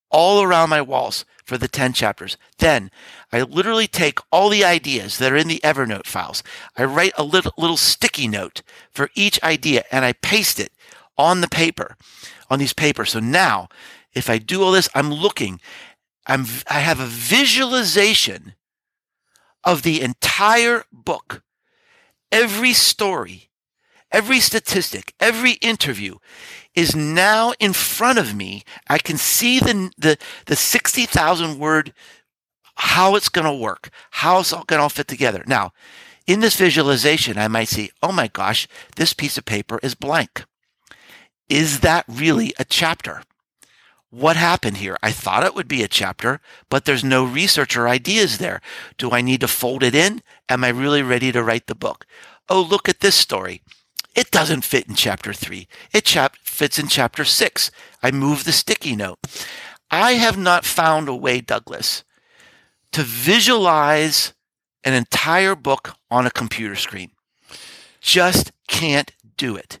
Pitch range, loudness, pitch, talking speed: 125-190 Hz, -17 LUFS, 150 Hz, 160 wpm